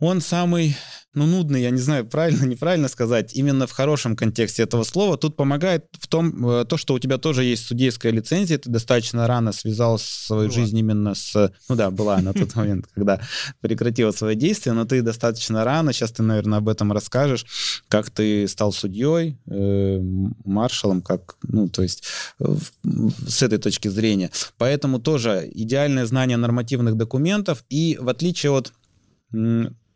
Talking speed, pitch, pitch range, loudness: 160 wpm, 120 Hz, 110-140 Hz, -21 LUFS